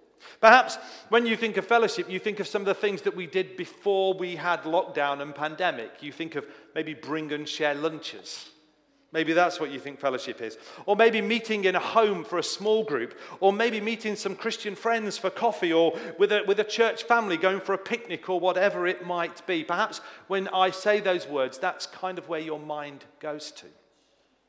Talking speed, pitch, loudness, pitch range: 210 wpm, 185 Hz, -26 LUFS, 160-210 Hz